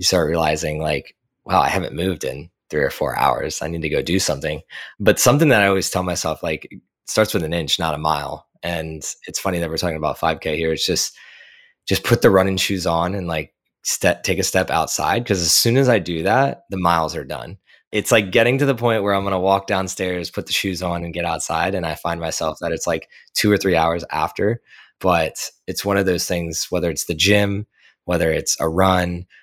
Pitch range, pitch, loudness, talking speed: 80-100 Hz, 90 Hz, -19 LUFS, 235 wpm